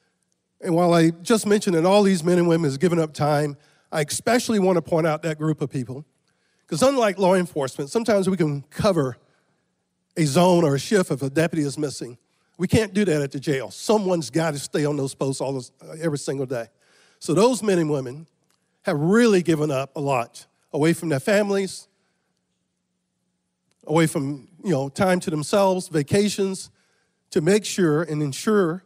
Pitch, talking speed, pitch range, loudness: 160 Hz, 185 wpm, 145-190 Hz, -22 LUFS